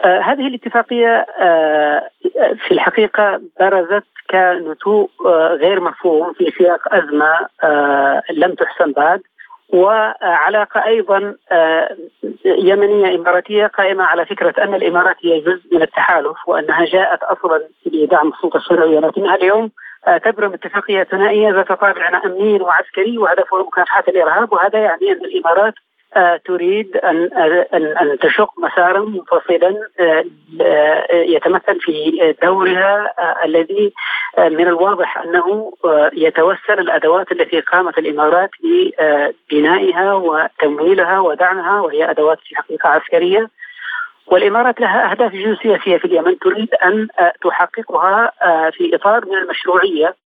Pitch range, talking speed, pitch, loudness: 170-215 Hz, 110 wpm, 190 Hz, -14 LUFS